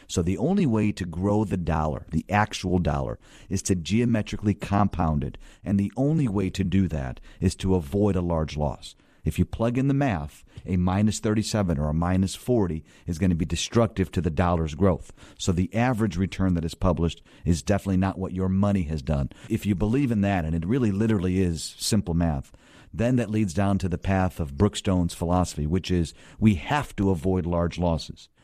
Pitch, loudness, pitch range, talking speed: 95 Hz, -25 LUFS, 85-105 Hz, 205 wpm